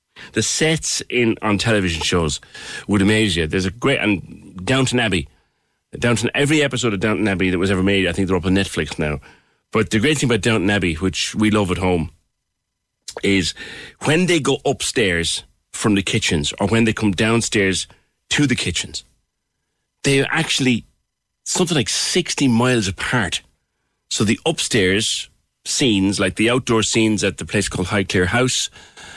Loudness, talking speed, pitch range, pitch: -18 LUFS, 165 wpm, 95-120 Hz, 105 Hz